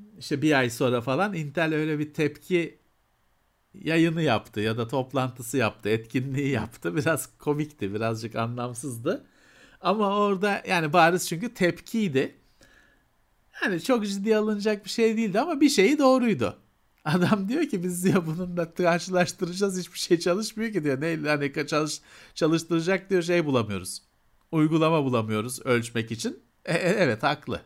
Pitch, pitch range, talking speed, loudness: 160 Hz, 130-190 Hz, 145 wpm, -26 LUFS